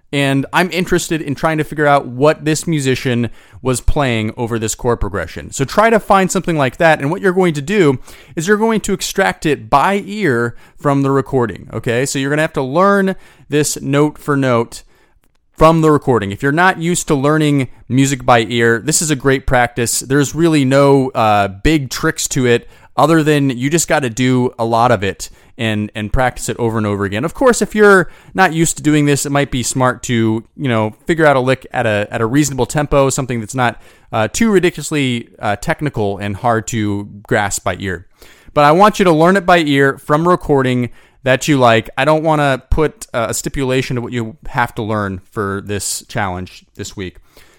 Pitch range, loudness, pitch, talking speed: 115-155 Hz, -15 LUFS, 135 Hz, 215 wpm